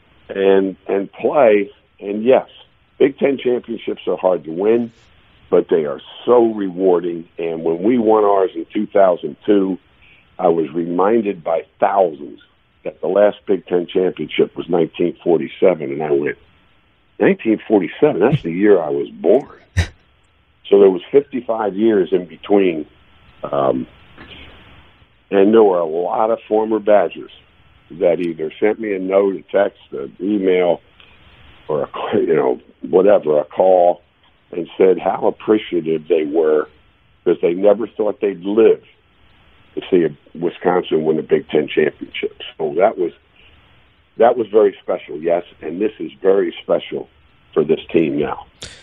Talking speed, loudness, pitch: 145 wpm, -17 LUFS, 105 Hz